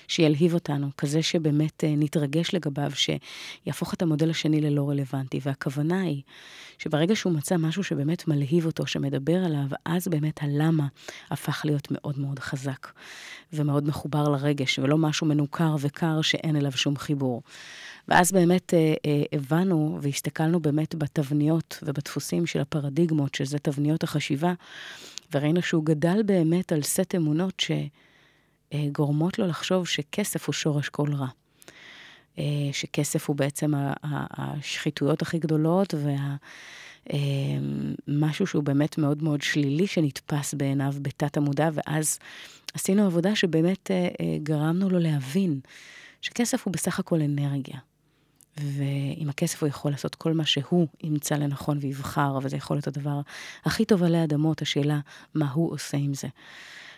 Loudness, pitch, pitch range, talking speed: -26 LUFS, 150 Hz, 145-165 Hz, 135 wpm